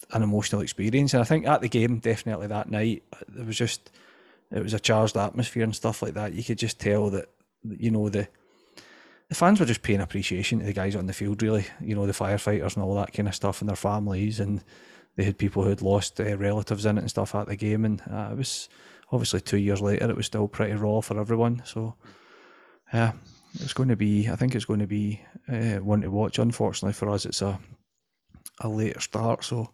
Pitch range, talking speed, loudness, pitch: 100-115 Hz, 230 wpm, -27 LUFS, 105 Hz